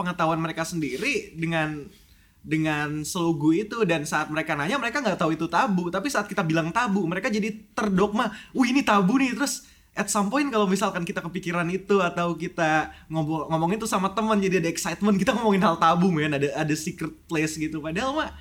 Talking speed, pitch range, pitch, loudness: 190 wpm, 160-210 Hz, 180 Hz, -25 LUFS